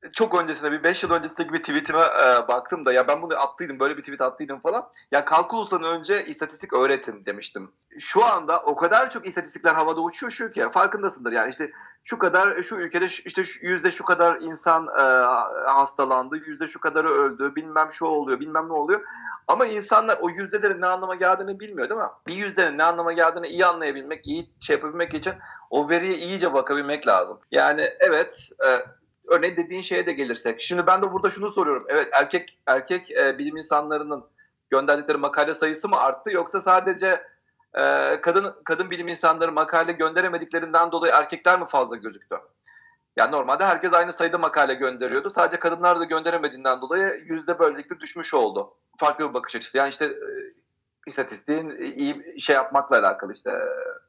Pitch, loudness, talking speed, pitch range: 170 Hz, -22 LUFS, 175 wpm, 155-185 Hz